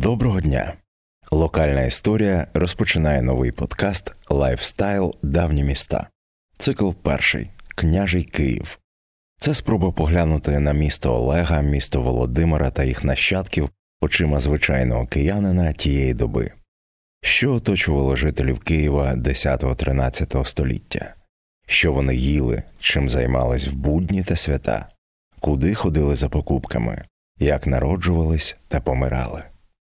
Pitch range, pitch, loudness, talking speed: 65-85 Hz, 75 Hz, -20 LUFS, 105 wpm